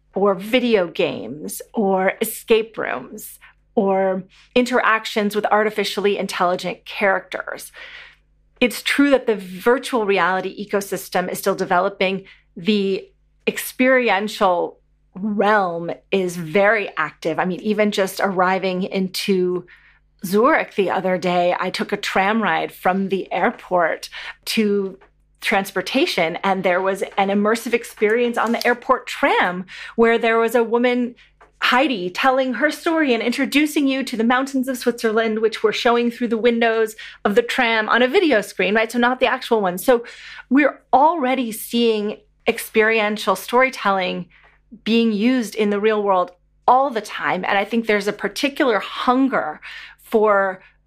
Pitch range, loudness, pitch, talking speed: 195-240 Hz, -19 LUFS, 215 Hz, 140 wpm